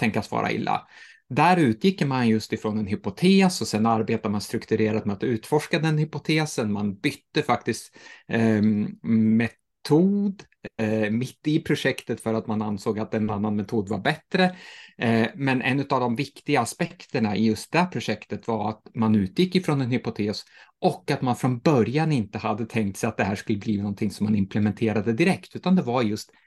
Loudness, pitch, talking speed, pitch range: -24 LUFS, 115 Hz, 185 wpm, 110-150 Hz